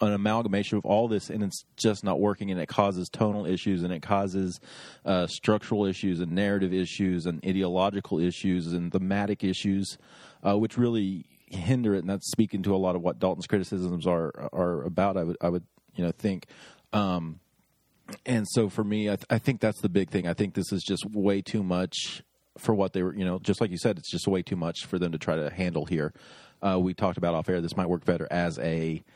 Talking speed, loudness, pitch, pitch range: 225 wpm, -28 LUFS, 95 Hz, 90-105 Hz